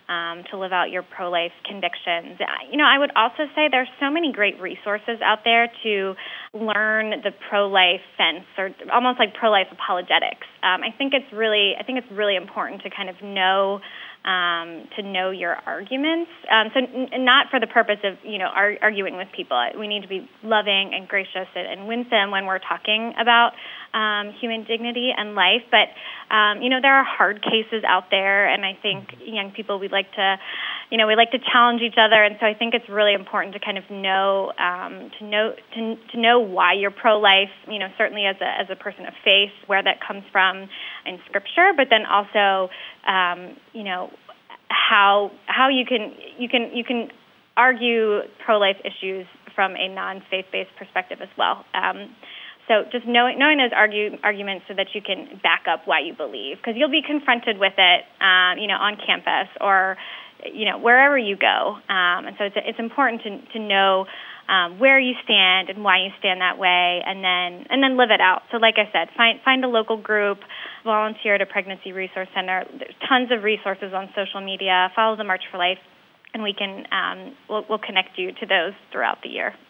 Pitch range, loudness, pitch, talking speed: 190-235 Hz, -20 LUFS, 210 Hz, 205 wpm